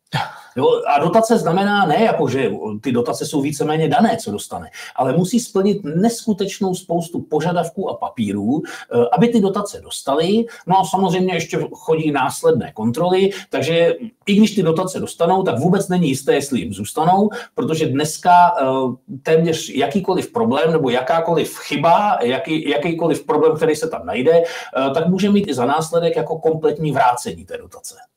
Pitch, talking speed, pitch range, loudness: 175 Hz, 150 wpm, 160-205 Hz, -18 LUFS